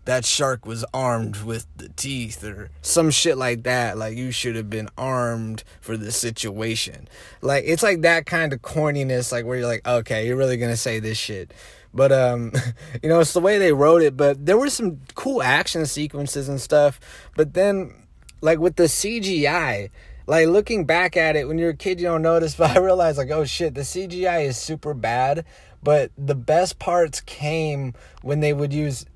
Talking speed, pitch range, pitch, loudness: 200 wpm, 120-165 Hz, 140 Hz, -21 LUFS